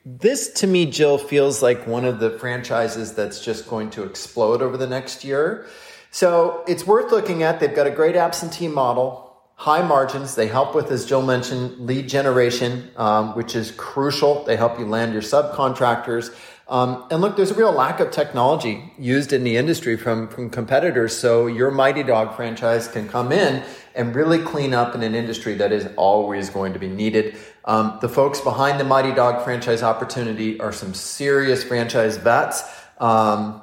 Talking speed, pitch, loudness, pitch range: 185 wpm, 125 Hz, -20 LUFS, 115-140 Hz